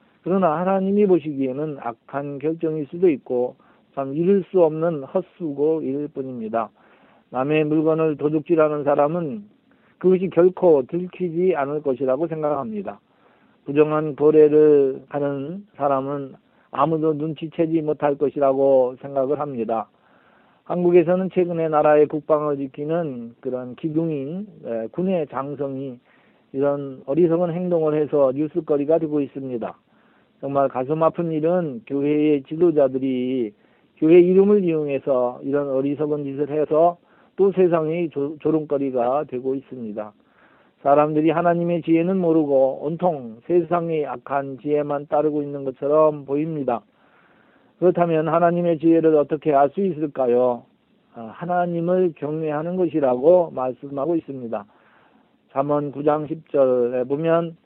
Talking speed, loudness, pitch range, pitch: 290 characters per minute, -21 LUFS, 140-170 Hz, 150 Hz